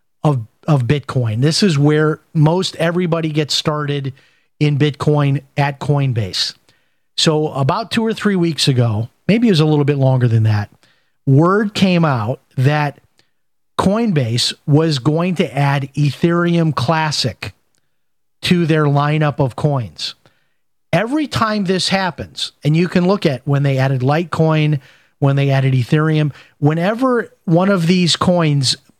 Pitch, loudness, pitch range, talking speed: 150 Hz, -16 LUFS, 140-170 Hz, 140 wpm